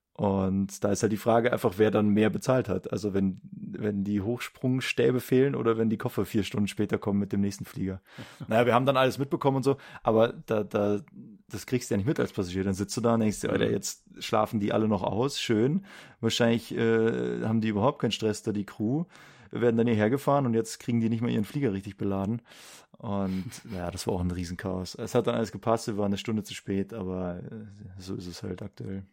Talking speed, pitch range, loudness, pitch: 235 wpm, 100-120 Hz, -28 LUFS, 110 Hz